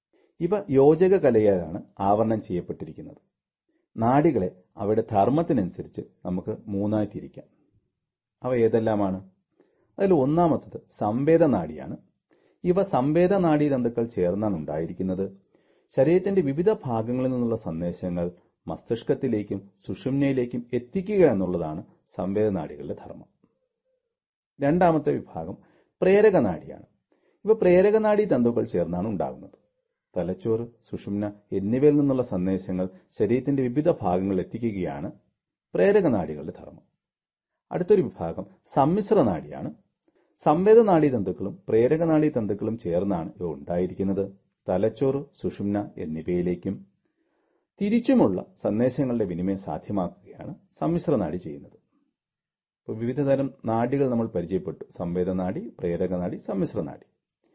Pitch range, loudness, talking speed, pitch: 95-150 Hz, -24 LUFS, 90 wpm, 115 Hz